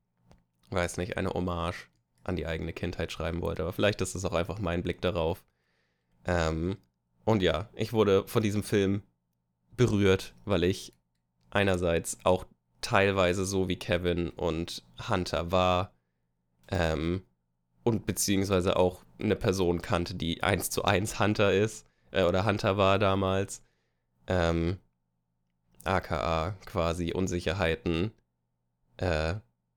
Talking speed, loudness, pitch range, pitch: 125 wpm, -29 LUFS, 60-95 Hz, 85 Hz